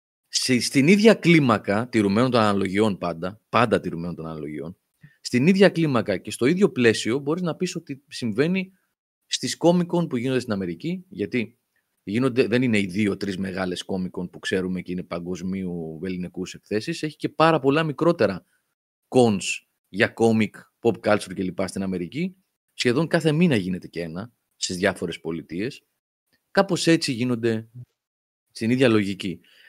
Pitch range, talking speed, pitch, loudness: 95-155 Hz, 145 wpm, 115 Hz, -23 LUFS